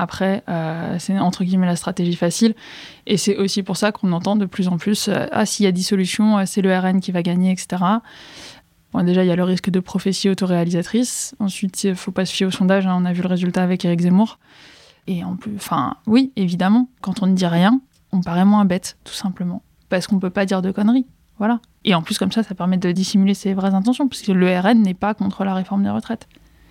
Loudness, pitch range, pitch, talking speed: -19 LUFS, 180-205 Hz, 190 Hz, 245 wpm